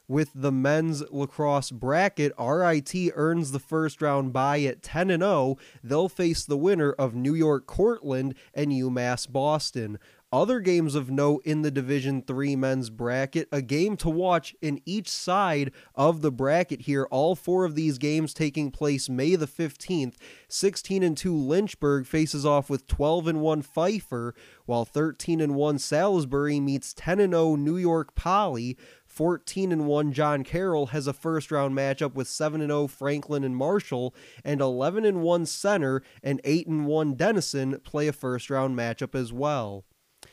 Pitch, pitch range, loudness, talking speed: 145 Hz, 135-160 Hz, -26 LUFS, 160 wpm